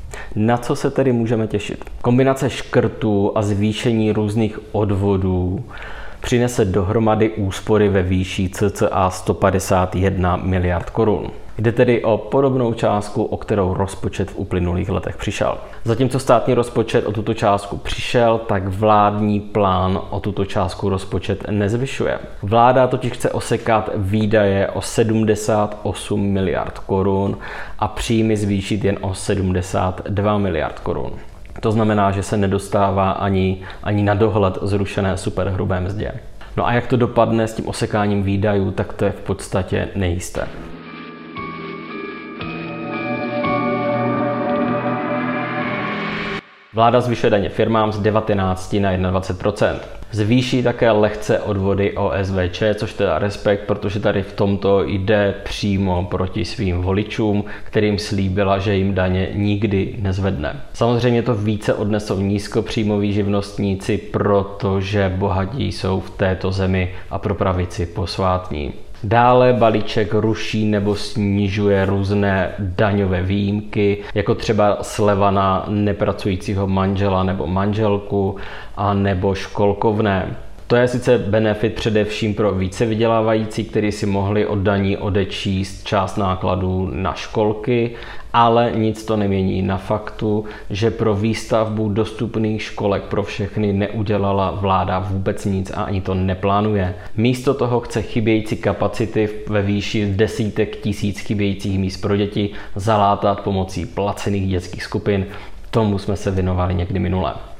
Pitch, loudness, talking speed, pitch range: 100 Hz, -19 LUFS, 125 wpm, 95-110 Hz